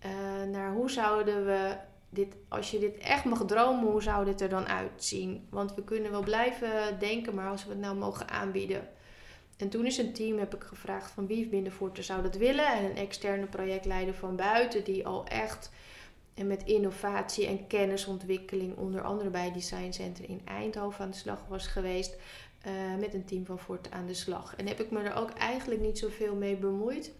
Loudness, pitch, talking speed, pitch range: -33 LUFS, 200 Hz, 205 wpm, 190-215 Hz